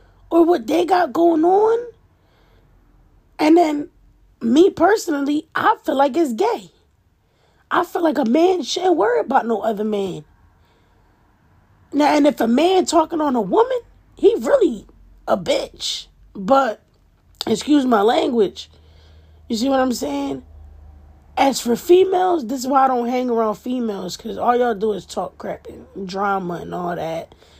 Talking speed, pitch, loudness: 155 wpm, 260 Hz, -18 LUFS